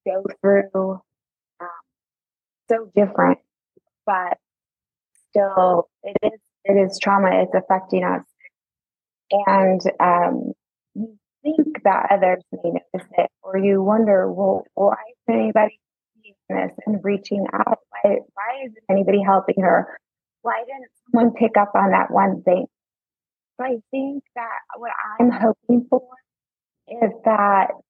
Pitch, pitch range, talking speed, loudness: 205 Hz, 195-230 Hz, 130 wpm, -20 LUFS